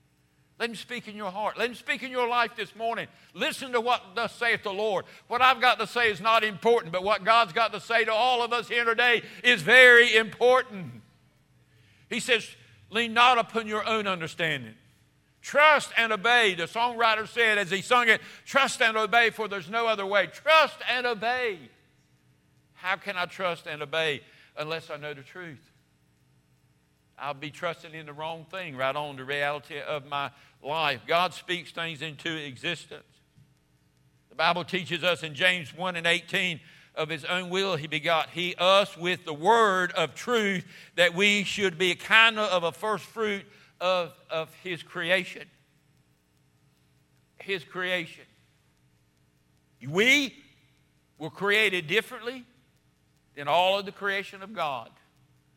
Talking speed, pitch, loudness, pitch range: 165 wpm, 185 Hz, -25 LUFS, 160-230 Hz